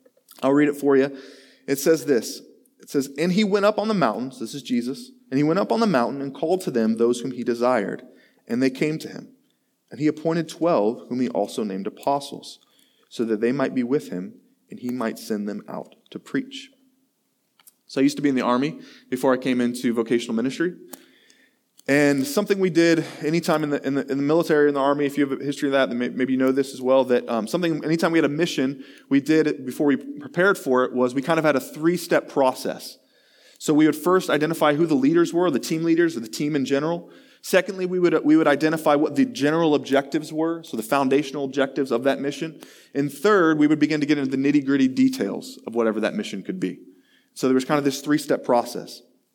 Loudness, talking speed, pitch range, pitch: -22 LUFS, 235 wpm, 135-170 Hz, 145 Hz